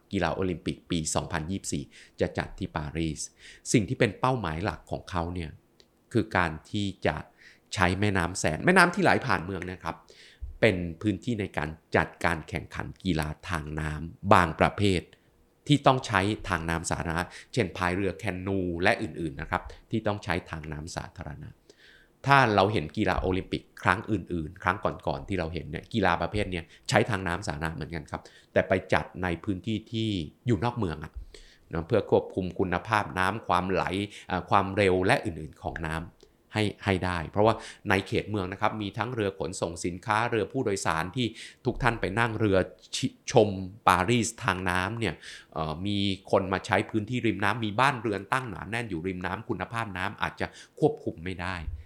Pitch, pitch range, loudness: 95 Hz, 85-105 Hz, -28 LUFS